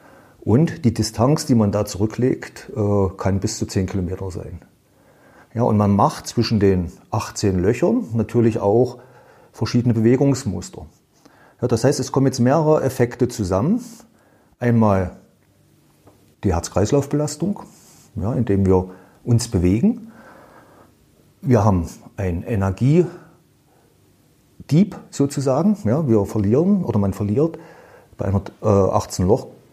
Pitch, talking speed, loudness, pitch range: 115 Hz, 115 wpm, -20 LUFS, 100-140 Hz